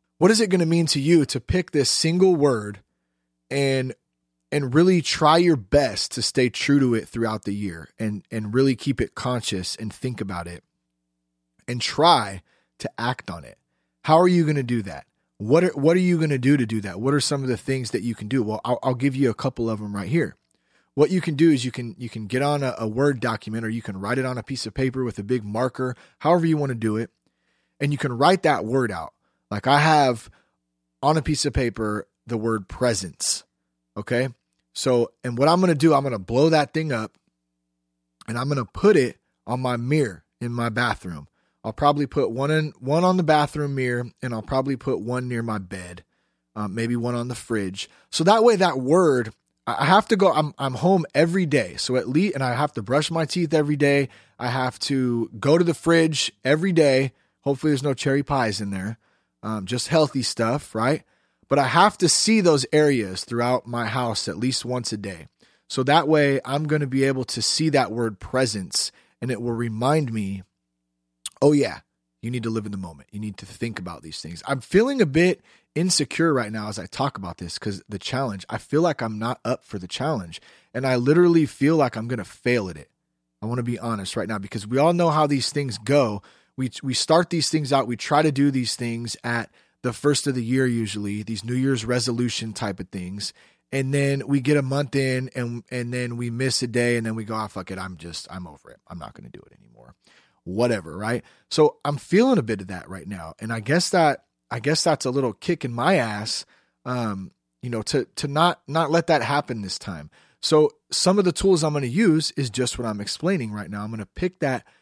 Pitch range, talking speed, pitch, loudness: 105-145 Hz, 235 wpm, 125 Hz, -22 LUFS